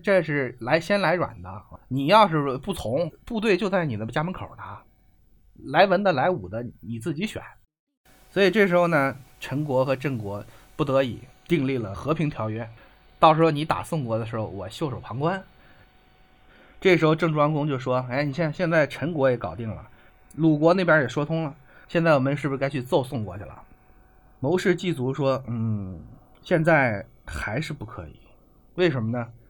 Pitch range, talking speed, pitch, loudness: 115-165 Hz, 260 characters per minute, 140 Hz, -24 LUFS